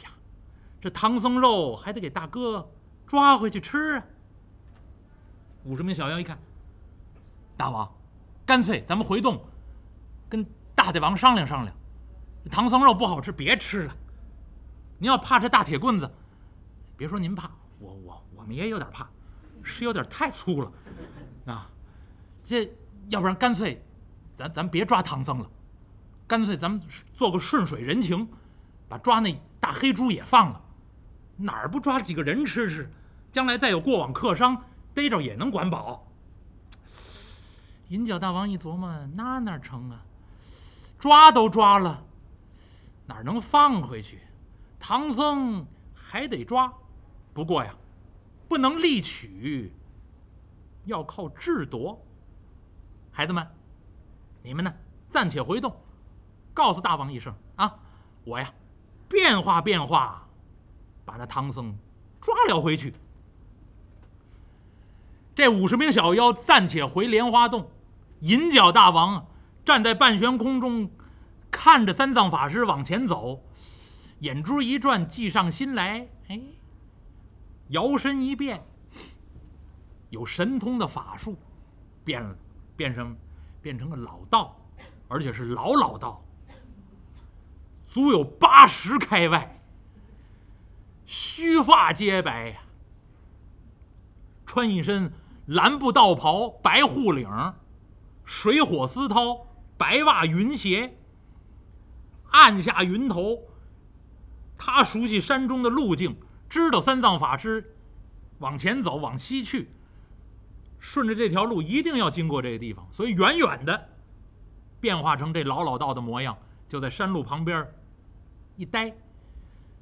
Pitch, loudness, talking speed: 130 Hz, -23 LUFS, 175 characters per minute